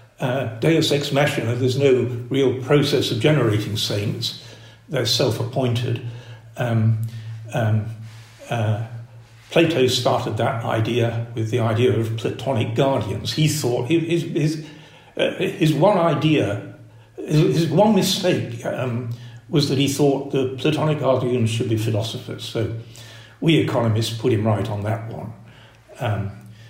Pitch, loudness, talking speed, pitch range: 120 Hz, -21 LUFS, 140 wpm, 115-145 Hz